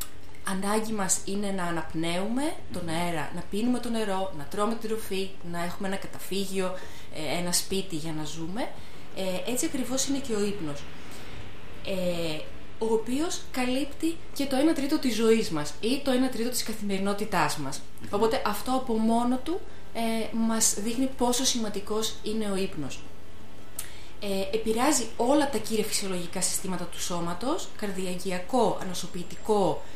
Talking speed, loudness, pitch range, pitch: 140 wpm, -29 LUFS, 180-235 Hz, 205 Hz